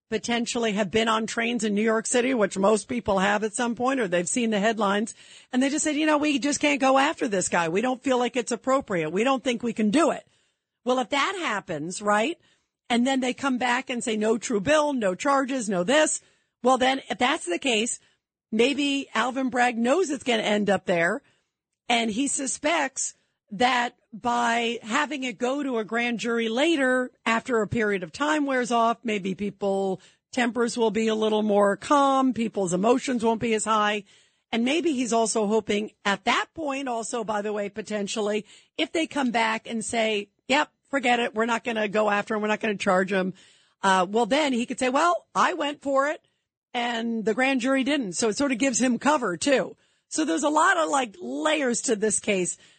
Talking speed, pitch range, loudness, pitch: 210 wpm, 215-270 Hz, -24 LUFS, 235 Hz